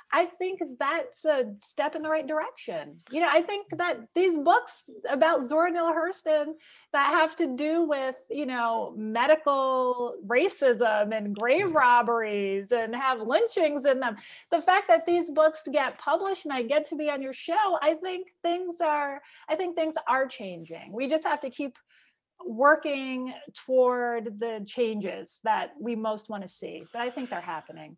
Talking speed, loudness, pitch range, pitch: 175 wpm, -27 LUFS, 240-330 Hz, 290 Hz